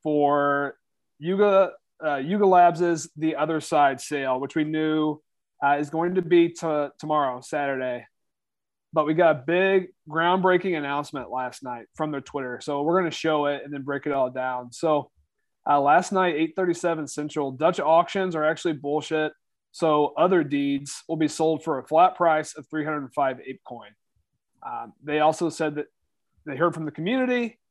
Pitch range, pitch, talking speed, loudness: 145-170 Hz, 155 Hz, 175 wpm, -24 LUFS